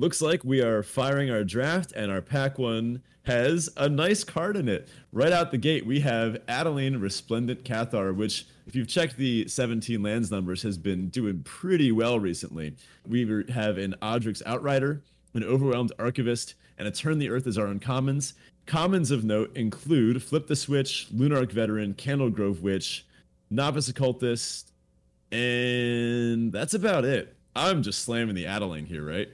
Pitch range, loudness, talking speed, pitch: 105-135 Hz, -27 LUFS, 165 wpm, 120 Hz